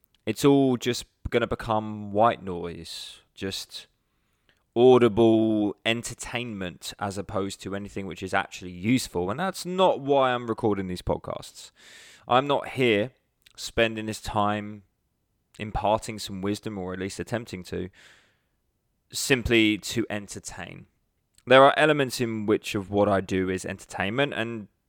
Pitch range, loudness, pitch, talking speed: 95-120 Hz, -25 LUFS, 105 Hz, 135 wpm